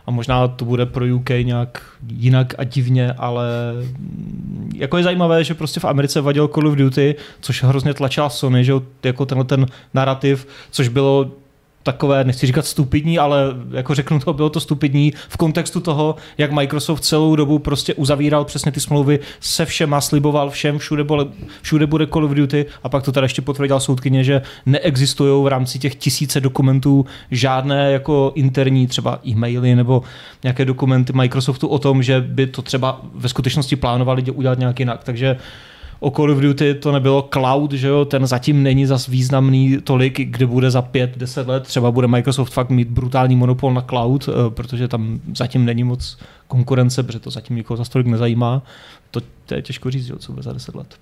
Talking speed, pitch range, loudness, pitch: 185 wpm, 130-145 Hz, -17 LUFS, 135 Hz